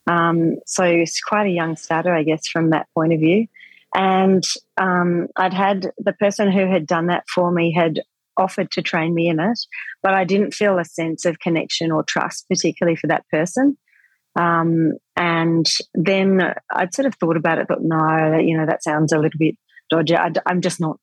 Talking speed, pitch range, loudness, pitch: 200 wpm, 165-190 Hz, -19 LUFS, 170 Hz